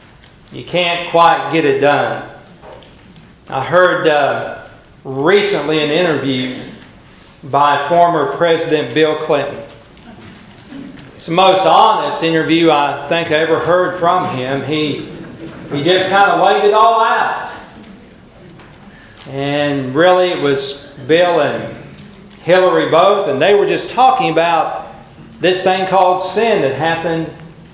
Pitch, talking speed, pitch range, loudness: 165 Hz, 125 wpm, 145-180 Hz, -13 LUFS